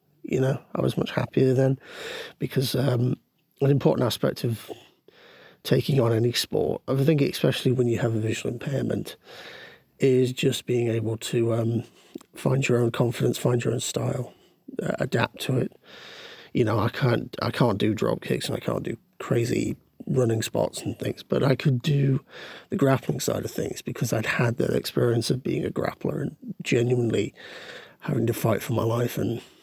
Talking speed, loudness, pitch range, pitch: 180 wpm, -25 LUFS, 120-135 Hz, 125 Hz